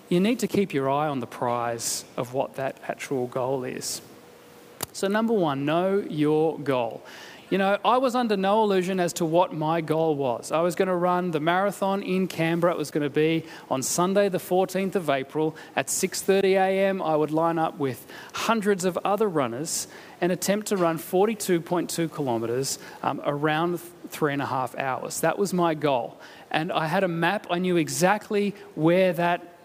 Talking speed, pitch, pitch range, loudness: 185 wpm, 175 Hz, 155-195 Hz, -25 LUFS